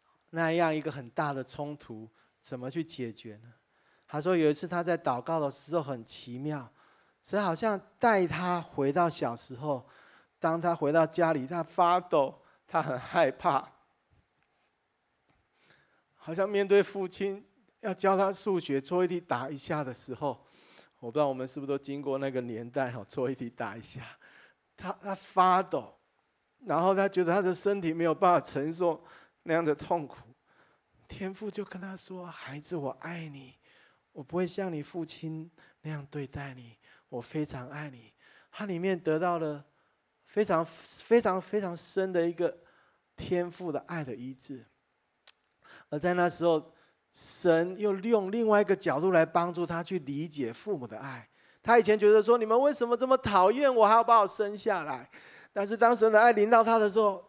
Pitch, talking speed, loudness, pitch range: 170 Hz, 245 characters per minute, -29 LUFS, 145-195 Hz